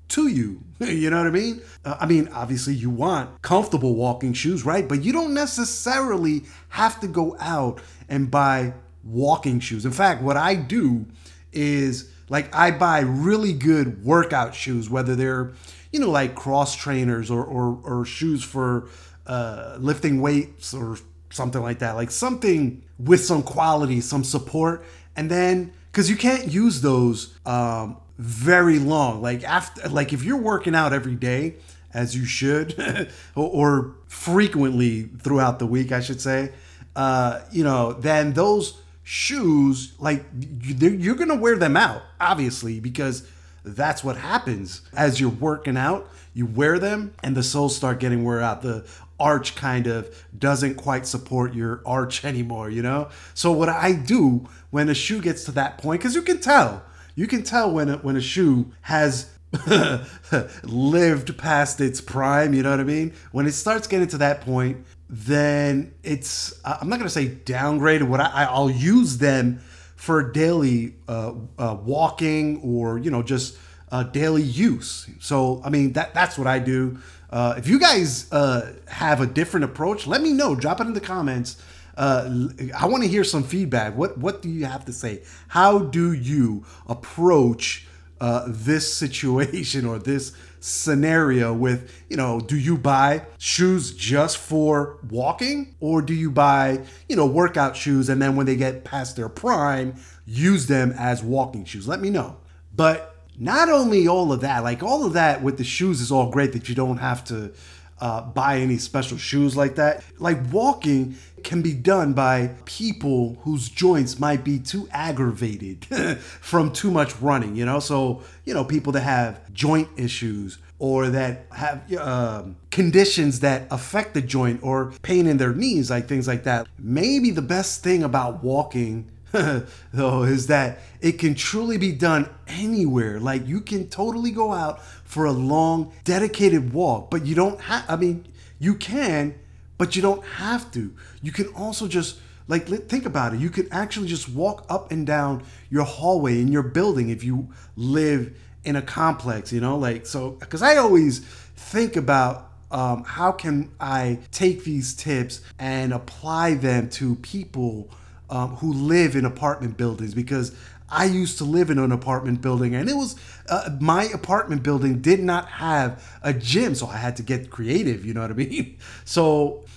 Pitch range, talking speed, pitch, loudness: 125-160 Hz, 170 wpm, 140 Hz, -22 LUFS